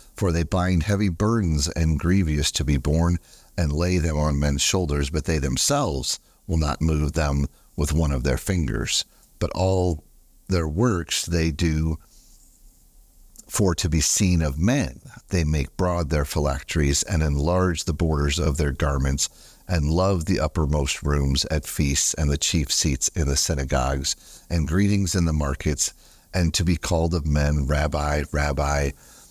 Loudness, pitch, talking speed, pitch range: -23 LUFS, 80 Hz, 160 wpm, 75-90 Hz